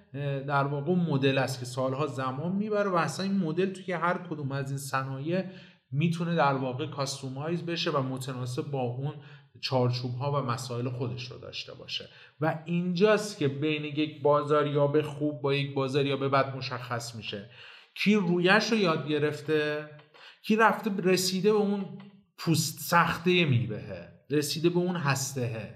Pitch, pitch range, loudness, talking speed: 150 Hz, 135-175 Hz, -29 LUFS, 160 wpm